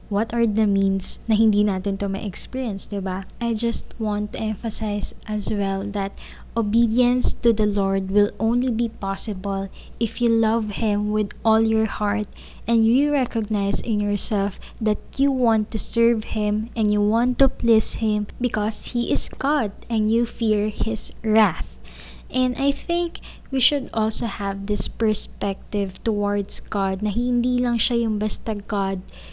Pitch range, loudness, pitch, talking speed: 205-230 Hz, -22 LUFS, 215 Hz, 165 wpm